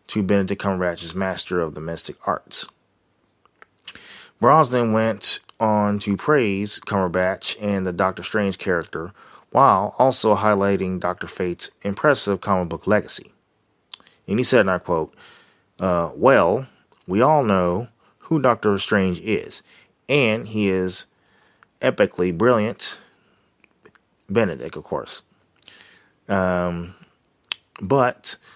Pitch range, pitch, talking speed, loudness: 90-105 Hz, 100 Hz, 110 wpm, -21 LUFS